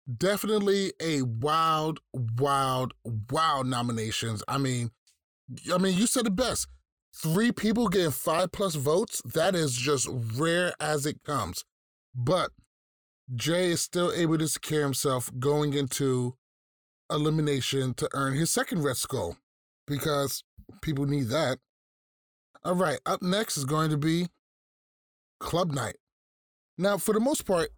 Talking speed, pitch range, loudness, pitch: 135 wpm, 125-170 Hz, -28 LUFS, 150 Hz